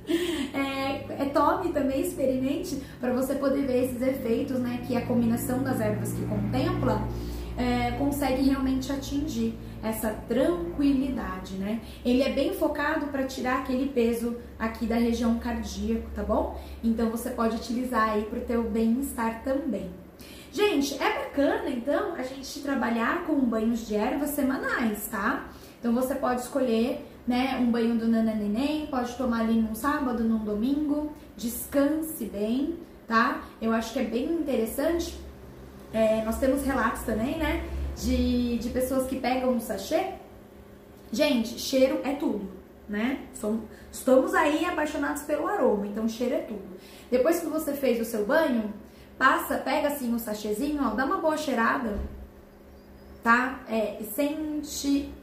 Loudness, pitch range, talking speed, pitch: -27 LUFS, 225-280 Hz, 145 wpm, 255 Hz